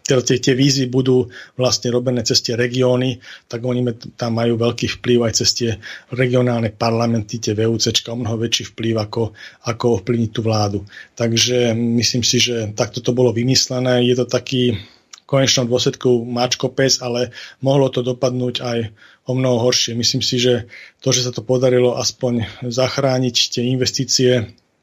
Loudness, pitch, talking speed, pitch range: -17 LUFS, 125 Hz, 160 wpm, 115-125 Hz